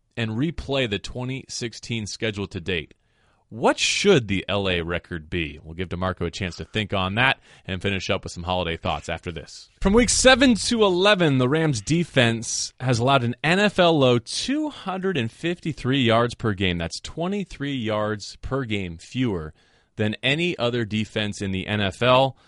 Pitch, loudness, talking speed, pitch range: 115 Hz, -23 LUFS, 165 wpm, 95-140 Hz